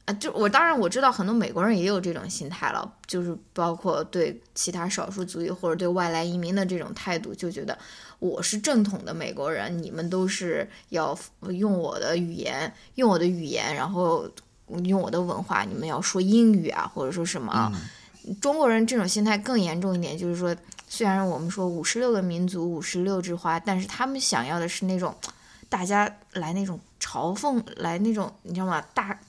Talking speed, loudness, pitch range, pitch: 295 characters per minute, -26 LUFS, 175-210 Hz, 185 Hz